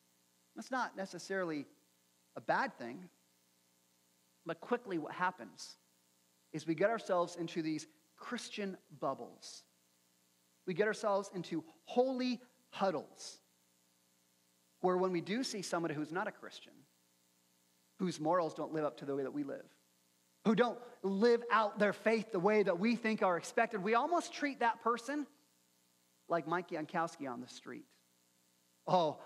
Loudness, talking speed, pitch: -37 LUFS, 145 wpm, 160 Hz